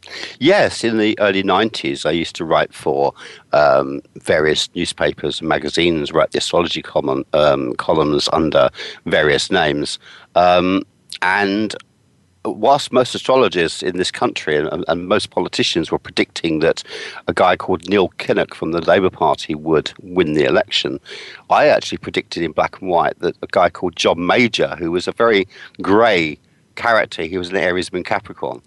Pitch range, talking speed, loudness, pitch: 85-110 Hz, 160 wpm, -17 LUFS, 95 Hz